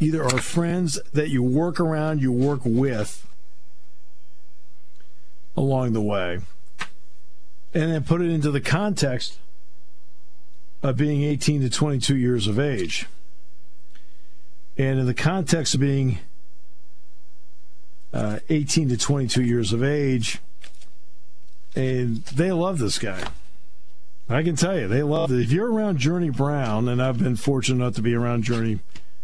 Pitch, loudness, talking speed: 120 Hz, -23 LUFS, 140 wpm